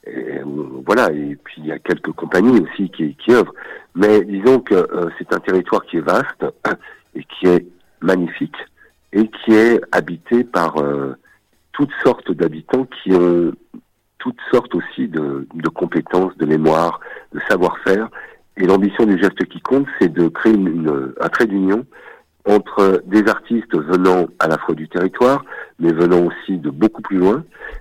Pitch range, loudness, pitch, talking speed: 85-105 Hz, -17 LUFS, 95 Hz, 170 wpm